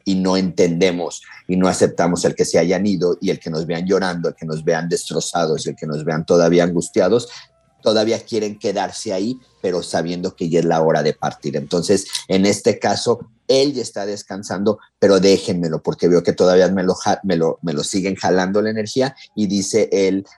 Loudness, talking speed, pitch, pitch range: -18 LUFS, 200 wpm, 95 Hz, 85-105 Hz